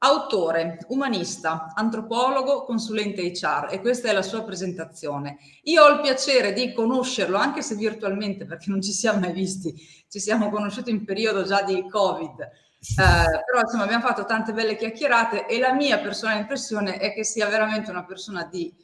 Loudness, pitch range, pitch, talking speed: -23 LUFS, 190-230 Hz, 210 Hz, 170 wpm